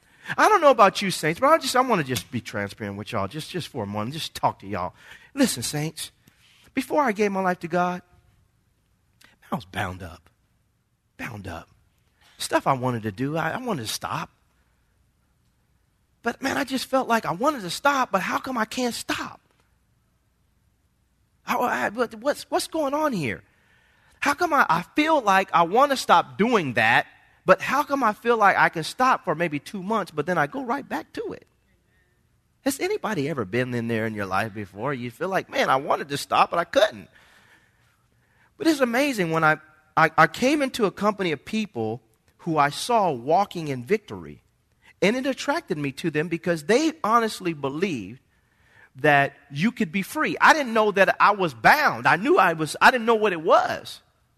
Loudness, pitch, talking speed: -23 LUFS, 185 Hz, 200 wpm